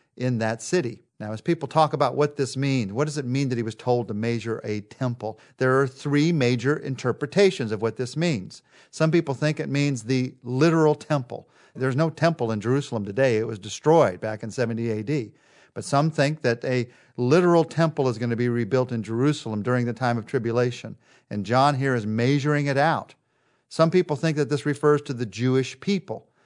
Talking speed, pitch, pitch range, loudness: 200 wpm, 130 Hz, 120-150 Hz, -24 LUFS